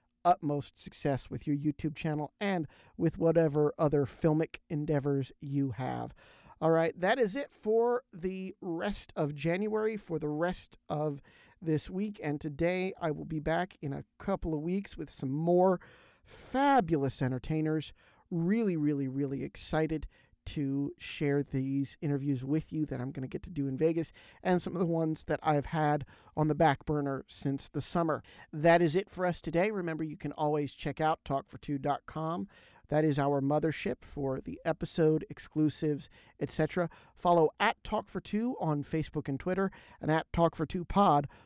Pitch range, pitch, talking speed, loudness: 145-175 Hz, 155 Hz, 170 wpm, -32 LUFS